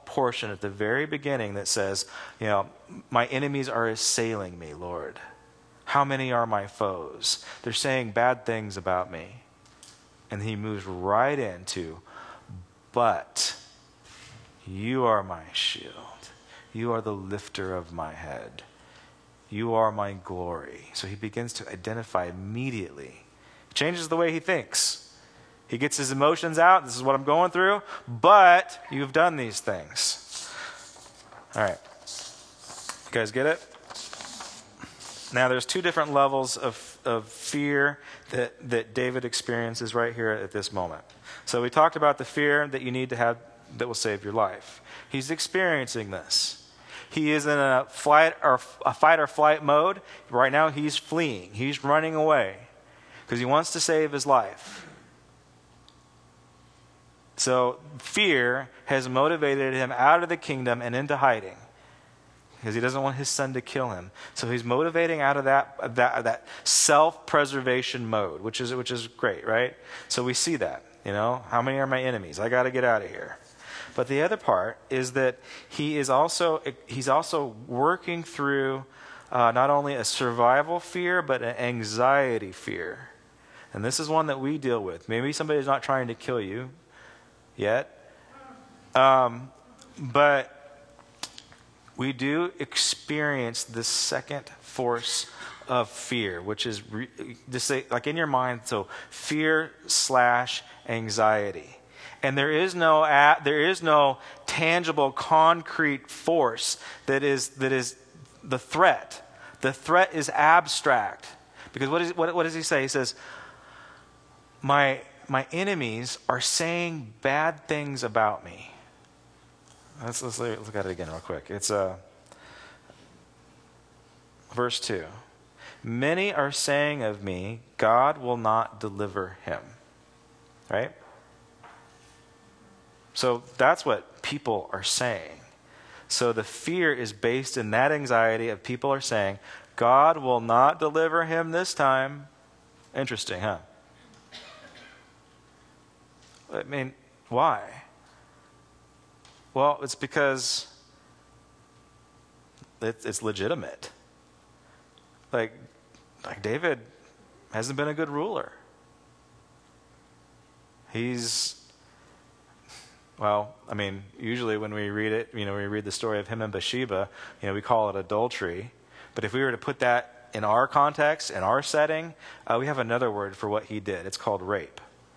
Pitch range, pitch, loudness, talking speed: 110-145 Hz, 125 Hz, -26 LUFS, 140 wpm